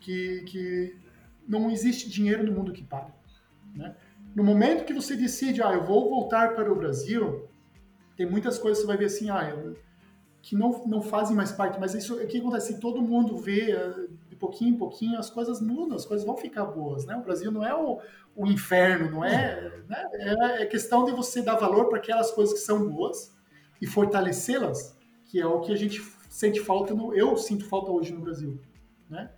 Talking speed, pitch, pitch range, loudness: 205 wpm, 210 Hz, 185-230 Hz, -27 LUFS